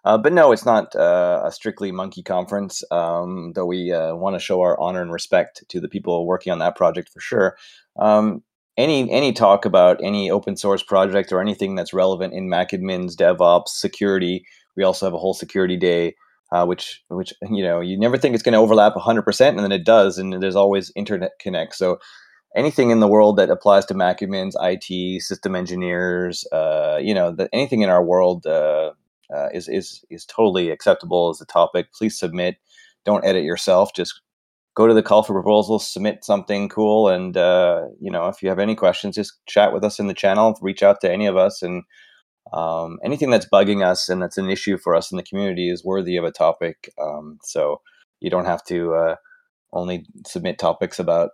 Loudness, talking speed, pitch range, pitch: -19 LUFS, 205 wpm, 90-105 Hz, 95 Hz